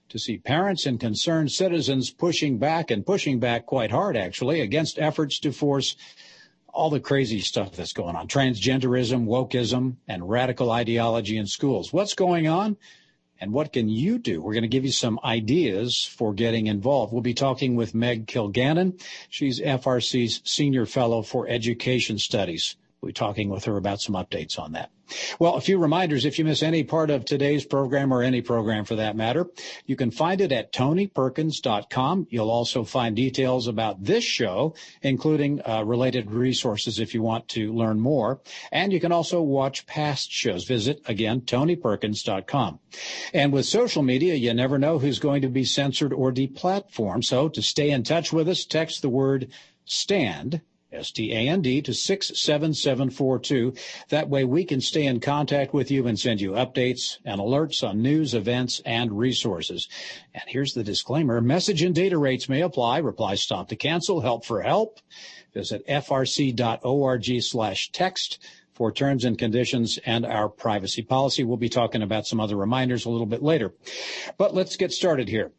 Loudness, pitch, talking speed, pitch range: -24 LUFS, 130 Hz, 175 wpm, 115-150 Hz